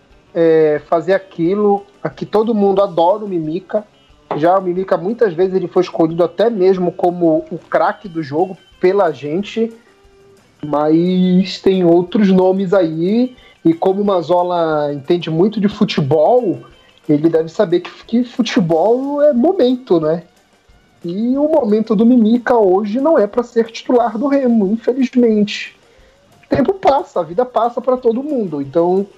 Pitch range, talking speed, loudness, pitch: 170-230 Hz, 145 wpm, -15 LUFS, 190 Hz